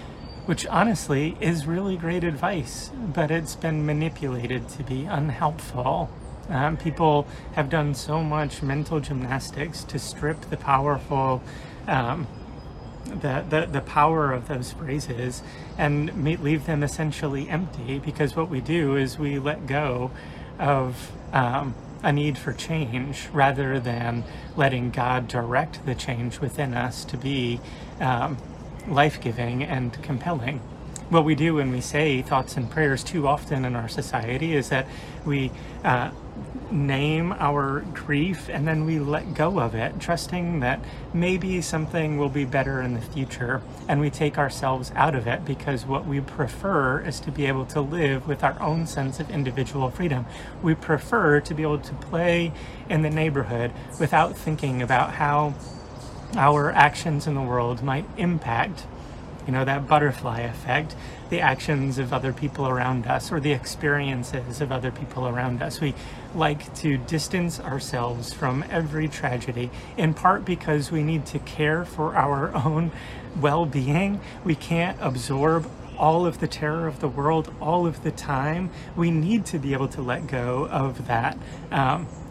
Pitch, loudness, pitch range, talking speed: 145 Hz, -25 LUFS, 130-155 Hz, 155 wpm